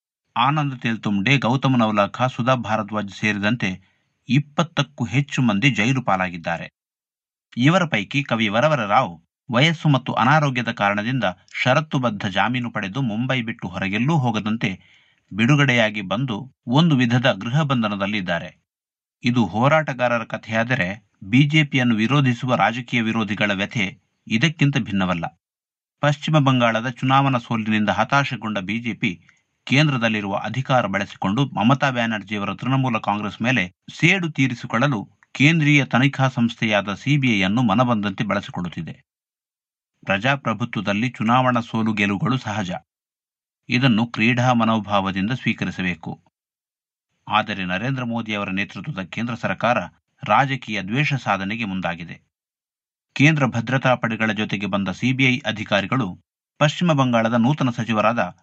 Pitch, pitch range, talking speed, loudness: 120 Hz, 105-135 Hz, 100 wpm, -20 LUFS